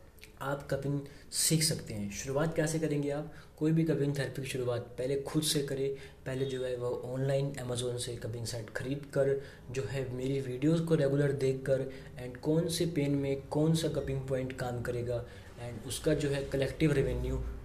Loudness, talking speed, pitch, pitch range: -33 LUFS, 185 wpm, 135 Hz, 125-145 Hz